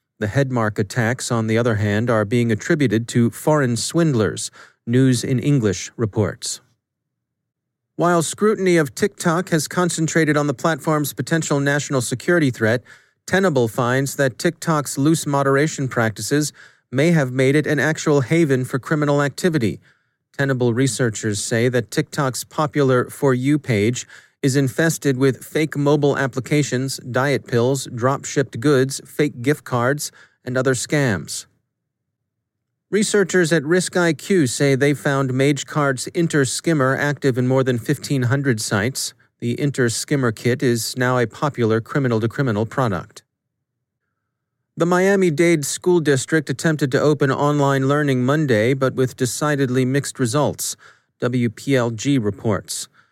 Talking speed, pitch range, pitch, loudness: 125 wpm, 125-150 Hz, 135 Hz, -19 LUFS